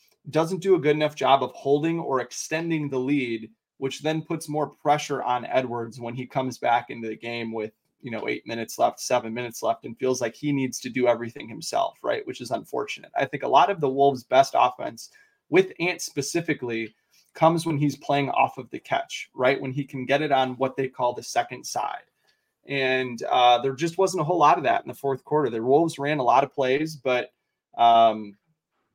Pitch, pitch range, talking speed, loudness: 135 Hz, 125-155 Hz, 215 wpm, -24 LUFS